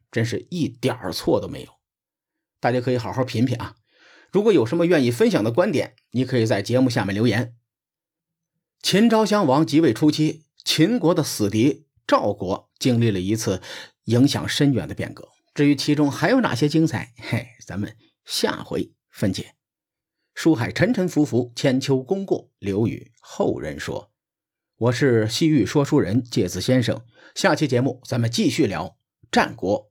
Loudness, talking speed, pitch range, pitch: -21 LUFS, 245 characters per minute, 115-150 Hz, 130 Hz